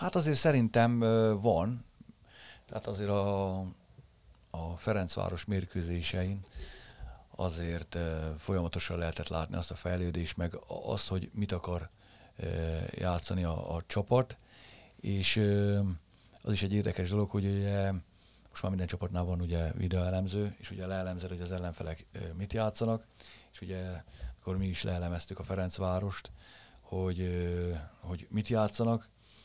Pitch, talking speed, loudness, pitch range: 95 Hz, 135 wpm, -34 LUFS, 85-105 Hz